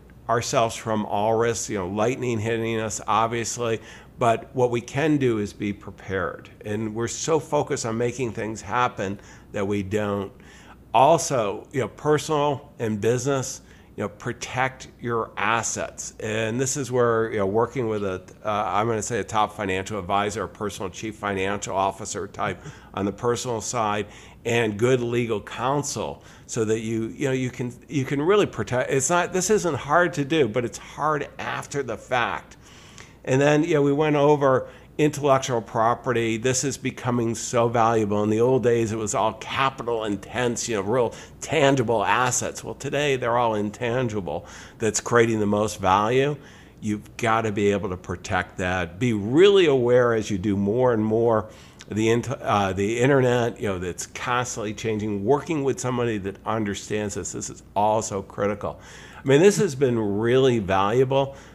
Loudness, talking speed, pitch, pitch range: -24 LUFS, 175 wpm, 115 Hz, 105-130 Hz